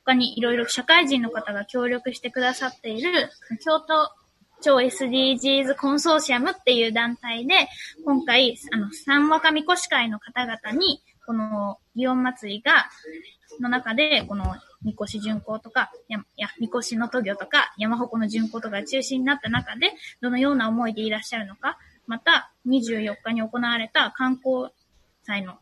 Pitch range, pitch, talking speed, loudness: 225-275 Hz, 245 Hz, 295 characters per minute, -23 LUFS